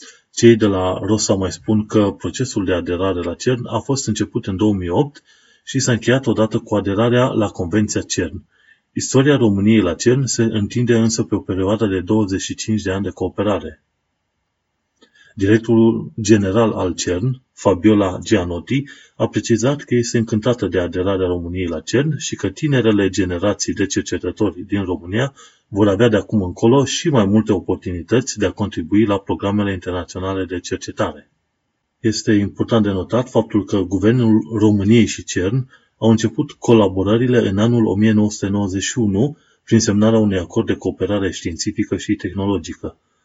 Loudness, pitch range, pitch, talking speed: -18 LUFS, 95-115 Hz, 105 Hz, 150 wpm